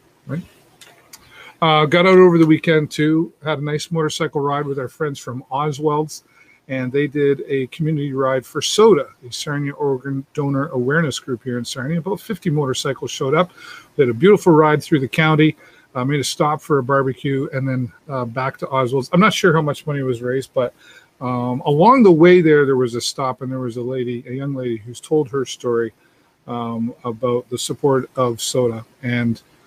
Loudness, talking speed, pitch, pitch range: -18 LUFS, 200 wpm, 140 Hz, 125-155 Hz